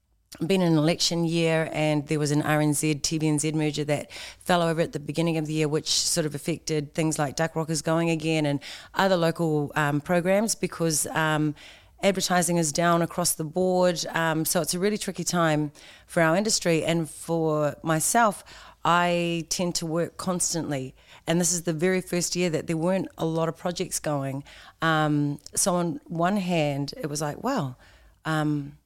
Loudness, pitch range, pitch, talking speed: -25 LUFS, 150-175 Hz, 160 Hz, 180 wpm